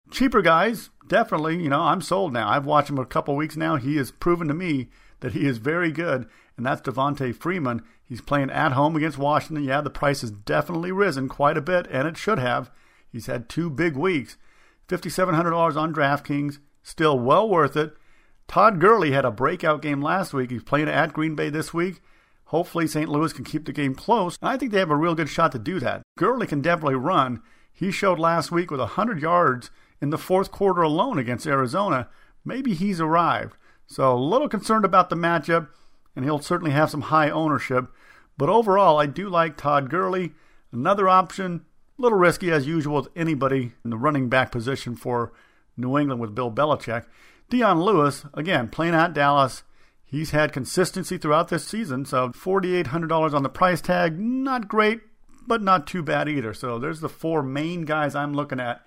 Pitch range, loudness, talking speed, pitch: 140-175 Hz, -23 LUFS, 195 wpm, 155 Hz